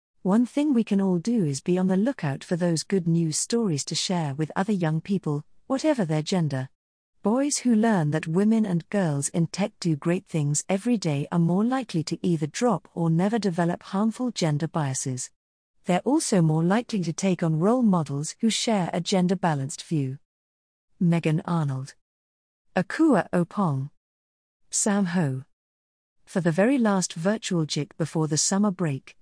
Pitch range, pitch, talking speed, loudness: 150-200 Hz, 175 Hz, 165 wpm, -25 LUFS